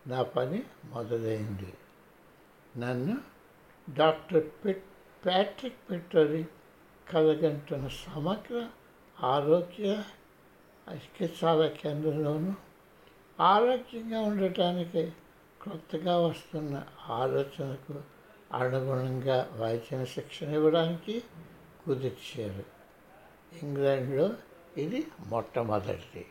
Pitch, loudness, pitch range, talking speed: 155 Hz, -31 LUFS, 135-175 Hz, 60 wpm